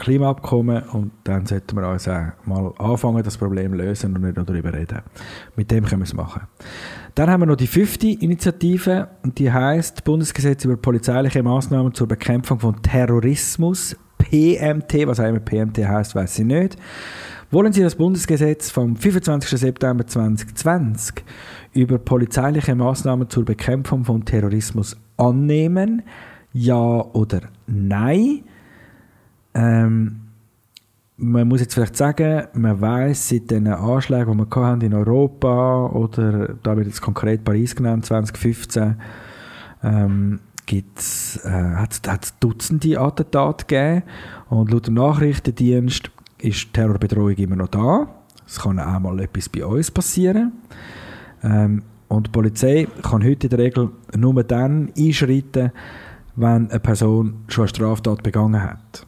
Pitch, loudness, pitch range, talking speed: 115 Hz, -19 LUFS, 110-135 Hz, 135 wpm